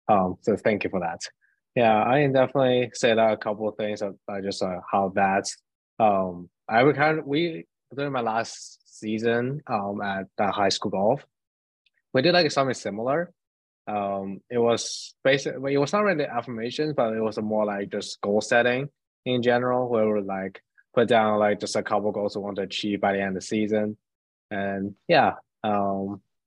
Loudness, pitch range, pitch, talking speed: -25 LUFS, 100-125 Hz, 105 Hz, 195 wpm